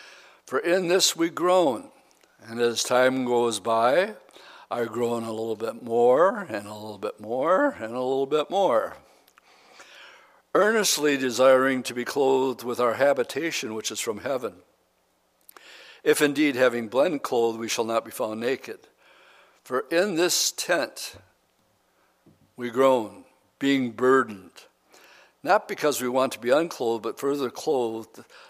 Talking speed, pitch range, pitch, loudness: 140 wpm, 115-150 Hz, 130 Hz, -24 LUFS